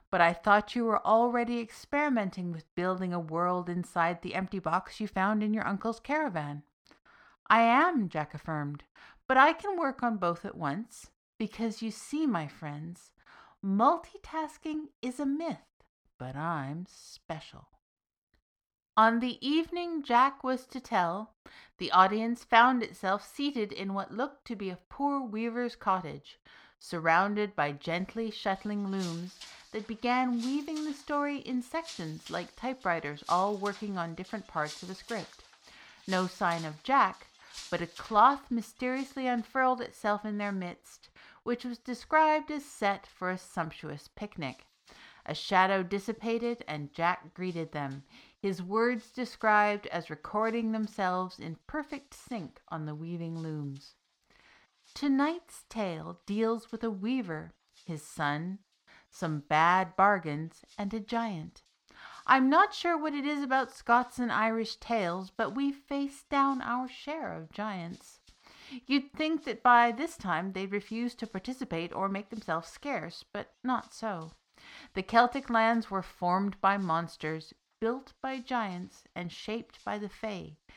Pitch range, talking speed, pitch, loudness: 180-250 Hz, 145 wpm, 215 Hz, -31 LUFS